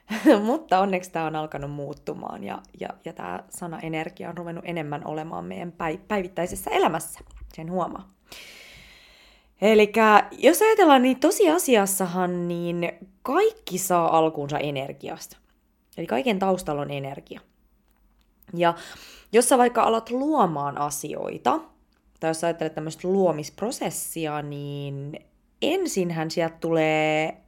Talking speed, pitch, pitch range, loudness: 115 wpm, 175 Hz, 155-210 Hz, -24 LUFS